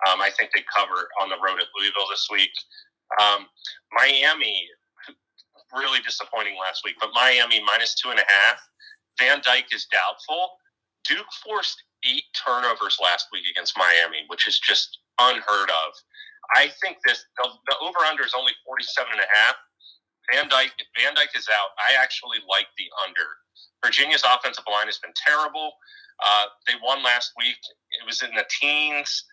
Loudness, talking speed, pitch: -21 LUFS, 170 wpm, 375 Hz